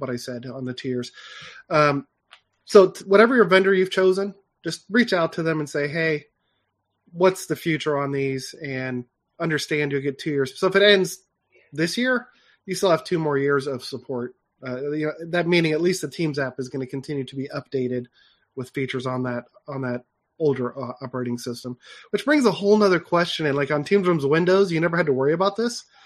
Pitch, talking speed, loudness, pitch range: 150 Hz, 215 wpm, -22 LUFS, 130-185 Hz